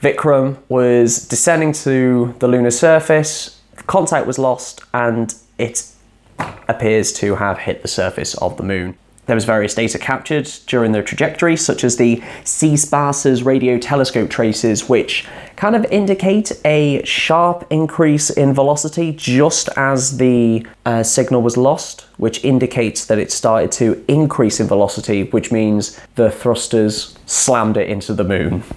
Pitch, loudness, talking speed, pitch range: 125 Hz, -15 LUFS, 150 wpm, 115-150 Hz